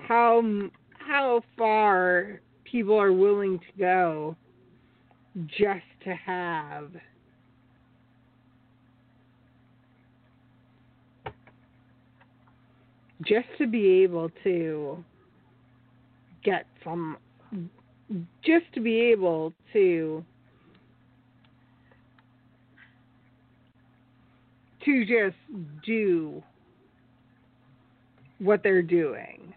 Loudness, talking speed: -25 LUFS, 60 wpm